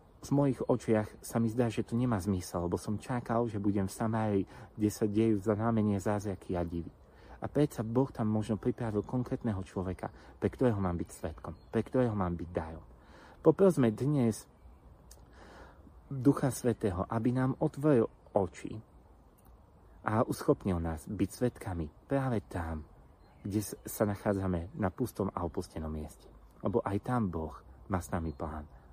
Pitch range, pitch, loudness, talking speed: 85-115 Hz, 105 Hz, -33 LUFS, 155 wpm